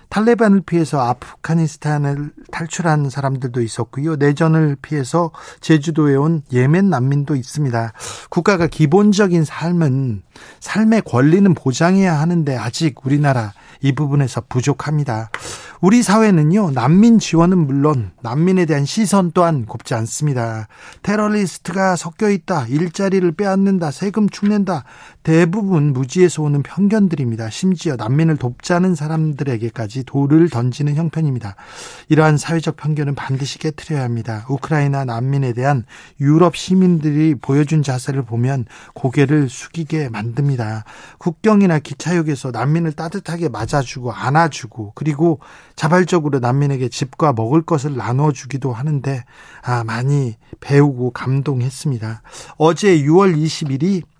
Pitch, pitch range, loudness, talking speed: 150 Hz, 135-170 Hz, -17 LUFS, 325 characters per minute